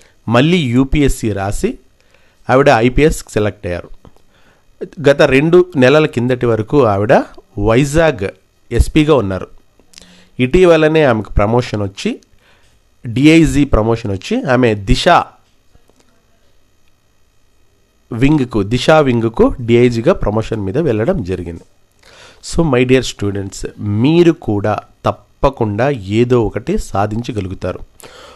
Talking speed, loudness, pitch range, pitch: 90 wpm, -13 LUFS, 100-140 Hz, 115 Hz